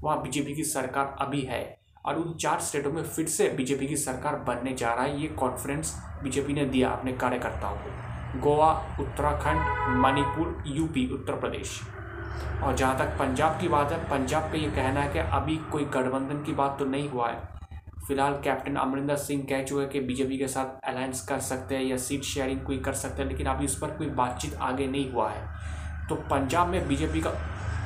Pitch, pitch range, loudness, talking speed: 135 Hz, 120-140 Hz, -29 LUFS, 200 wpm